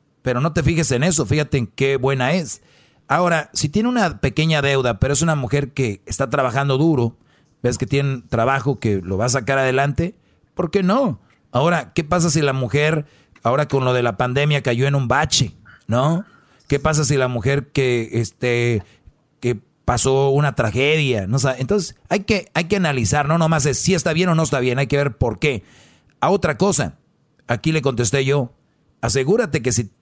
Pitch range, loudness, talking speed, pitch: 125-155 Hz, -19 LUFS, 200 wpm, 140 Hz